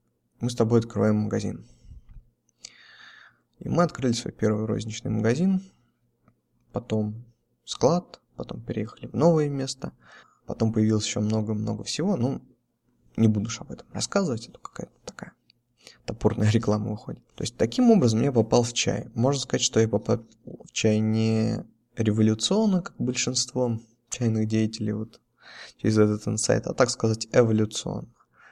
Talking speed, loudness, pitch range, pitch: 140 wpm, -25 LUFS, 110-125 Hz, 115 Hz